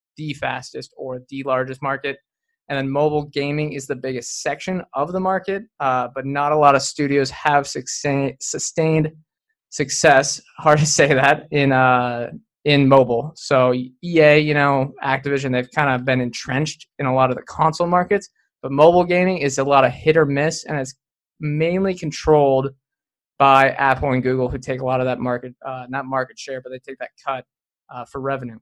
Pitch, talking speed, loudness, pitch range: 140 Hz, 185 wpm, -19 LUFS, 130-150 Hz